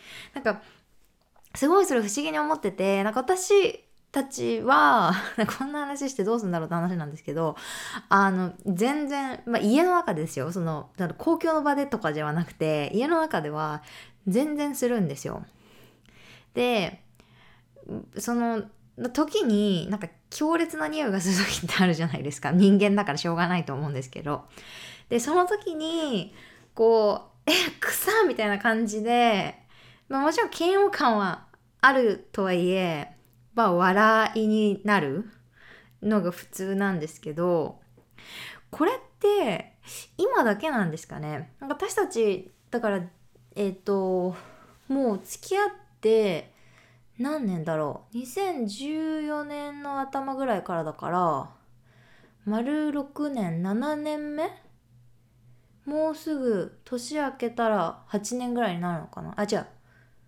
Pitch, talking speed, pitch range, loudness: 210 Hz, 260 characters per minute, 170-280 Hz, -26 LUFS